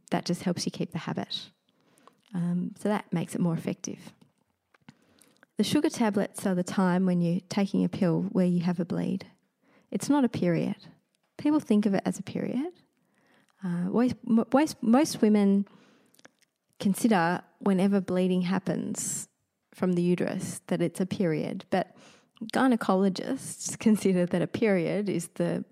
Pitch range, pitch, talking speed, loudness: 180-235 Hz, 200 Hz, 150 wpm, -28 LUFS